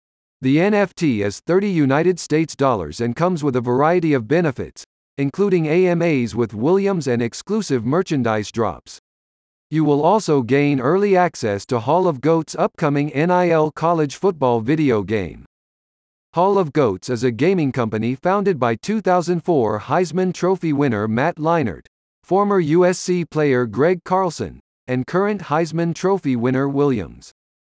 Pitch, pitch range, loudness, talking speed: 150 Hz, 125-180 Hz, -19 LUFS, 140 wpm